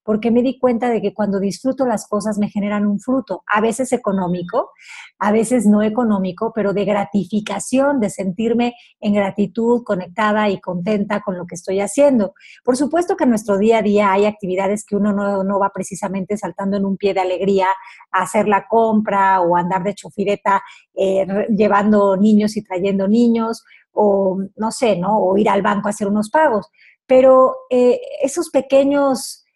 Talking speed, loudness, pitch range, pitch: 175 wpm, -17 LUFS, 195-230 Hz, 205 Hz